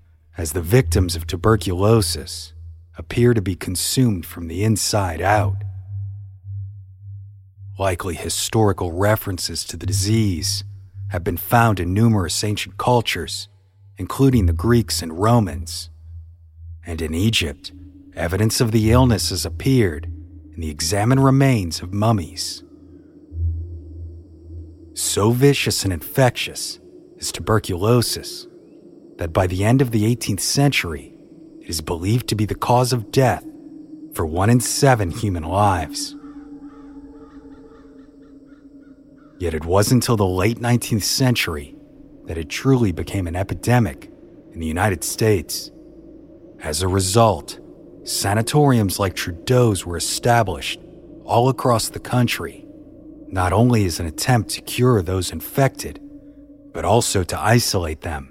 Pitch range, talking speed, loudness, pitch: 85-120 Hz, 120 wpm, -19 LUFS, 100 Hz